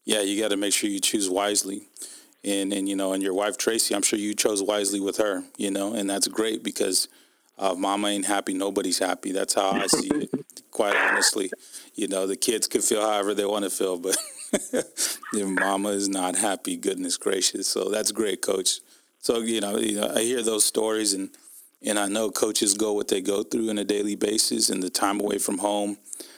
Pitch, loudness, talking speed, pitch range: 105 Hz, -24 LUFS, 215 wpm, 100-110 Hz